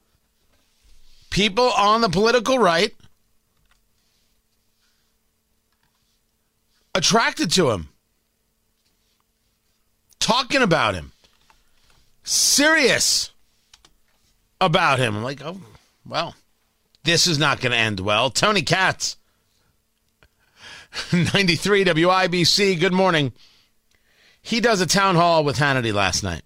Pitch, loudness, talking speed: 170 Hz, -18 LUFS, 90 wpm